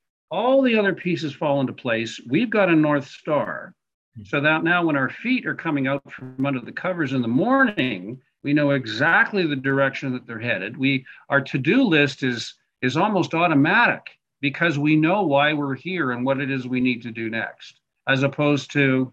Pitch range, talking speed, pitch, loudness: 130-165 Hz, 195 wpm, 140 Hz, -21 LUFS